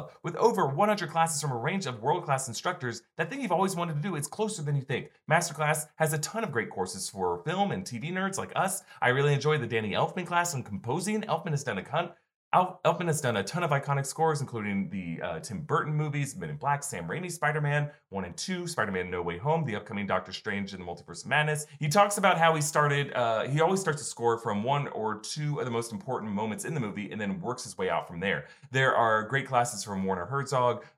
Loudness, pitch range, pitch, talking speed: -29 LUFS, 120-165 Hz, 150 Hz, 245 wpm